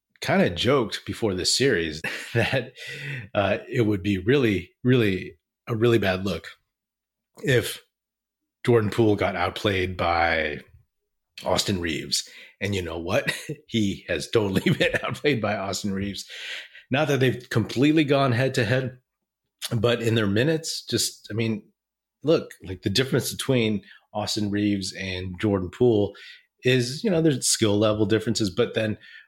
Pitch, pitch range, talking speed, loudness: 110 Hz, 100-130 Hz, 145 wpm, -24 LUFS